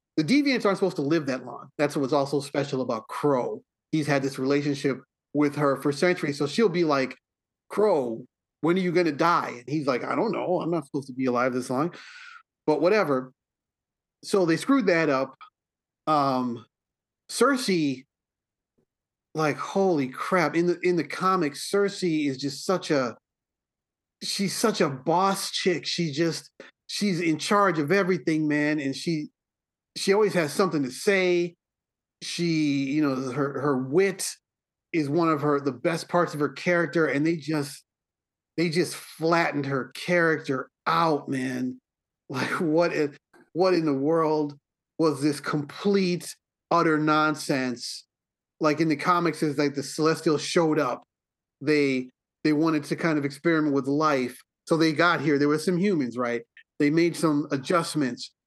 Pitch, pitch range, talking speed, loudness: 155 Hz, 140-175 Hz, 165 wpm, -25 LUFS